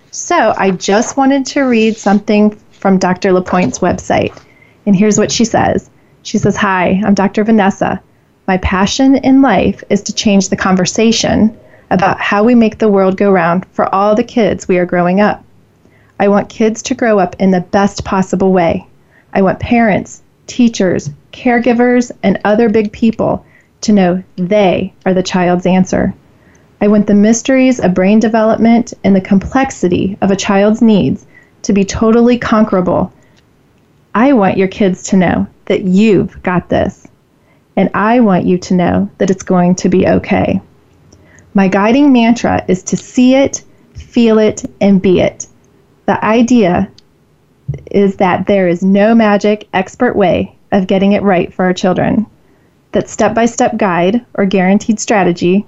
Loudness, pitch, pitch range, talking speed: -11 LUFS, 200 Hz, 190-225 Hz, 165 wpm